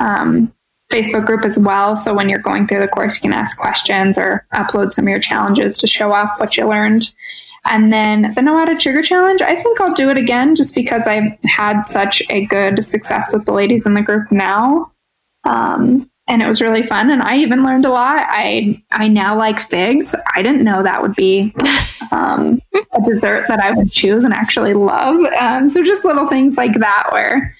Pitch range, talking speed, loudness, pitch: 210-275 Hz, 215 wpm, -13 LUFS, 225 Hz